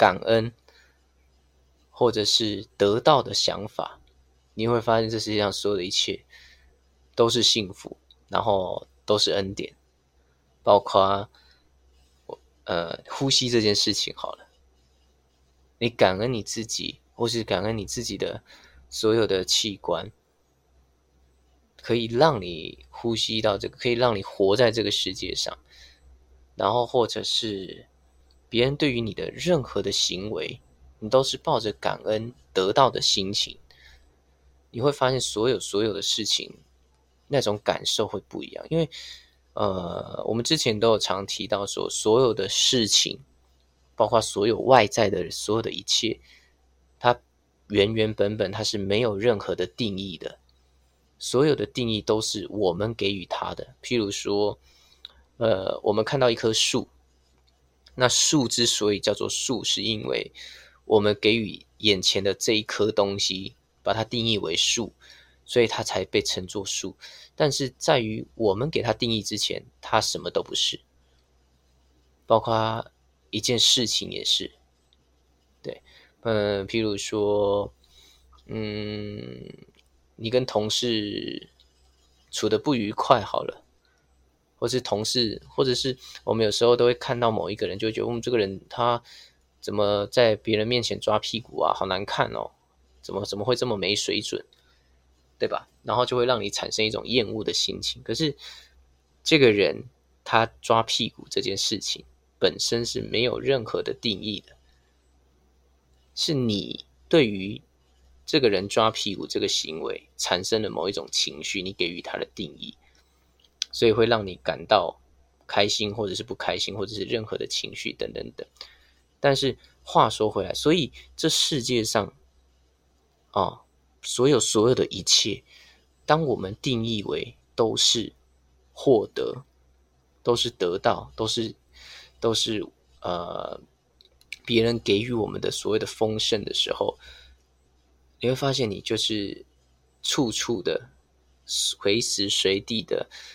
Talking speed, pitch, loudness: 210 characters per minute, 95 Hz, -24 LUFS